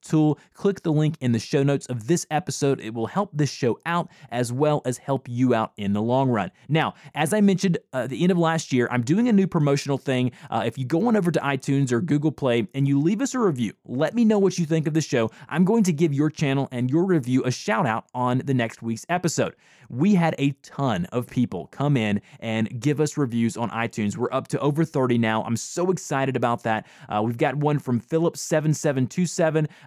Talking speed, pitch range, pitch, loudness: 235 wpm, 125-160 Hz, 140 Hz, -23 LUFS